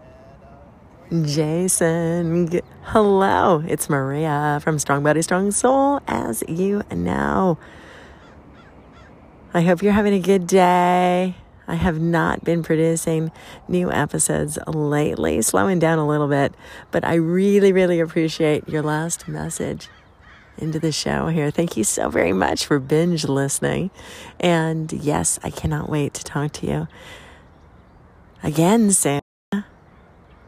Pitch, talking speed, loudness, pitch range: 160 Hz, 125 wpm, -20 LUFS, 145-180 Hz